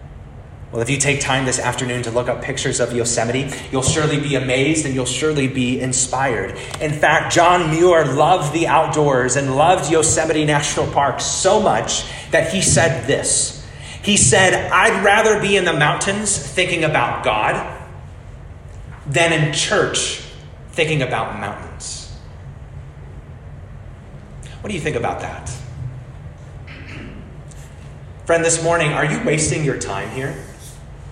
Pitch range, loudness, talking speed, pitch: 125-160 Hz, -17 LUFS, 140 wpm, 140 Hz